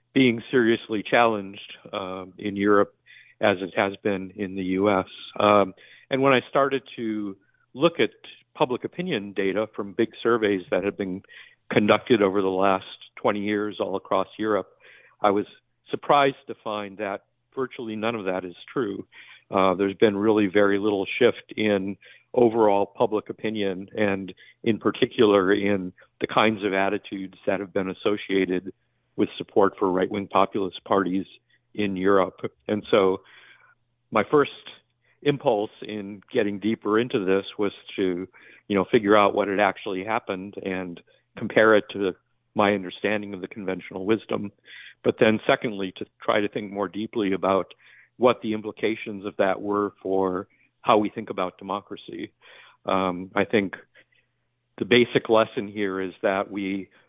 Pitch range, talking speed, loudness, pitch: 95-110 Hz, 150 wpm, -24 LUFS, 100 Hz